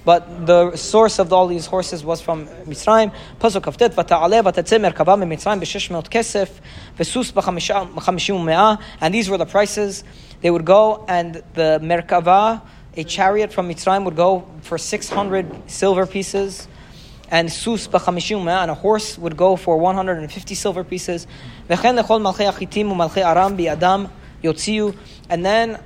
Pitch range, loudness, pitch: 170-205 Hz, -18 LUFS, 185 Hz